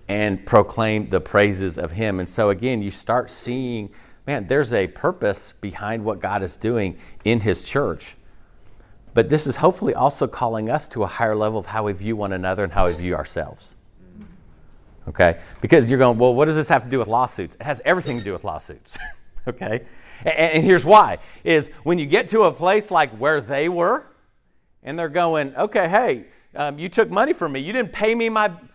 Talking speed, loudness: 200 wpm, -20 LUFS